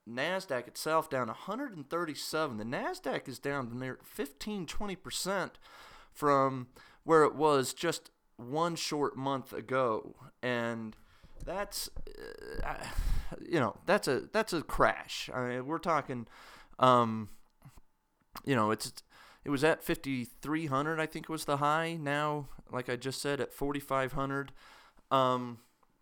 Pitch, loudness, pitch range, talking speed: 140 Hz, -33 LUFS, 125-160 Hz, 130 wpm